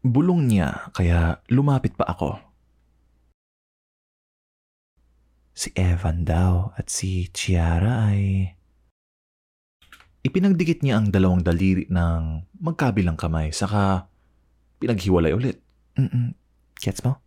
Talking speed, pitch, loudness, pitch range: 95 wpm, 90 Hz, -23 LUFS, 70-110 Hz